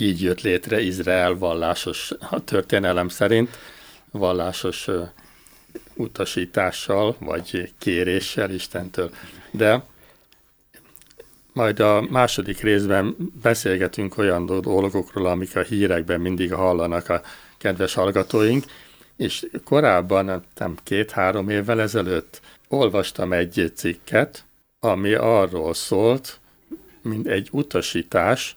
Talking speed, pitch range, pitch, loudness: 90 wpm, 90-105 Hz, 95 Hz, -22 LUFS